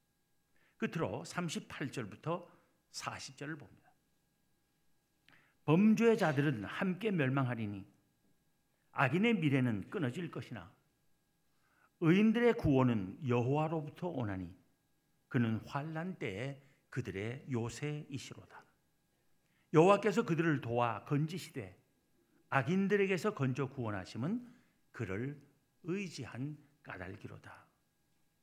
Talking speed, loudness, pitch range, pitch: 215 characters per minute, -35 LUFS, 125-165 Hz, 145 Hz